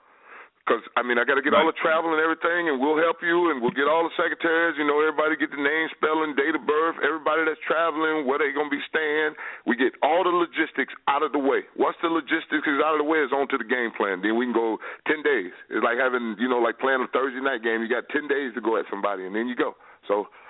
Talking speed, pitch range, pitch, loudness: 270 wpm, 130-165 Hz, 155 Hz, -24 LUFS